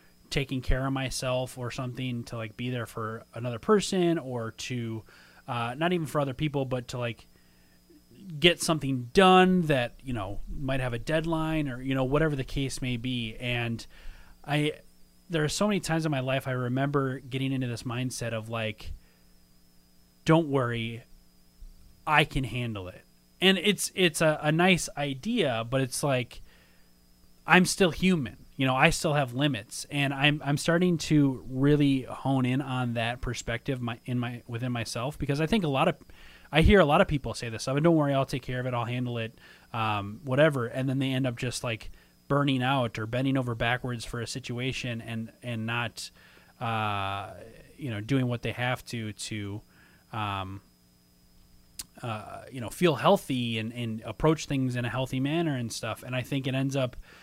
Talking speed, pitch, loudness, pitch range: 185 wpm, 125 Hz, -28 LUFS, 115-145 Hz